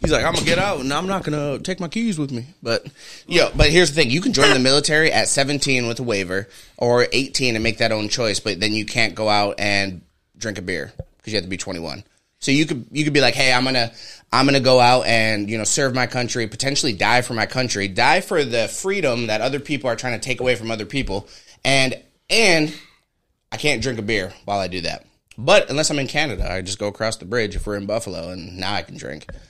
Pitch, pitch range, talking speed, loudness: 120 Hz, 105-140 Hz, 260 wpm, -19 LUFS